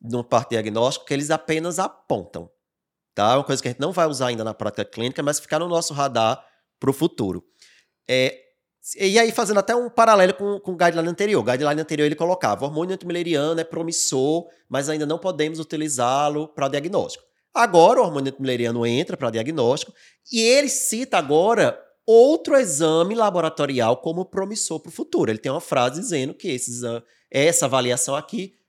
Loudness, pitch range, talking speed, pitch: -21 LUFS, 135-195 Hz, 180 wpm, 160 Hz